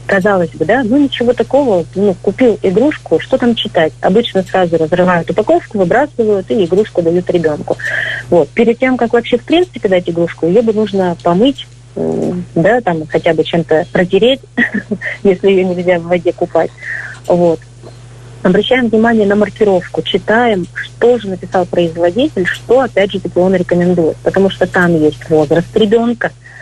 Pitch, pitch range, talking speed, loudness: 185 Hz, 170-220 Hz, 150 wpm, -12 LUFS